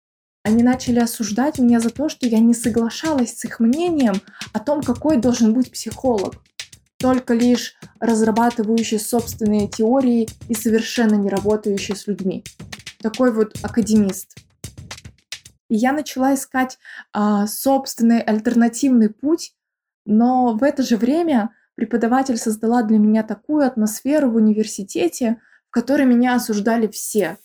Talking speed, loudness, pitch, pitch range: 130 wpm, -19 LUFS, 235 Hz, 220-255 Hz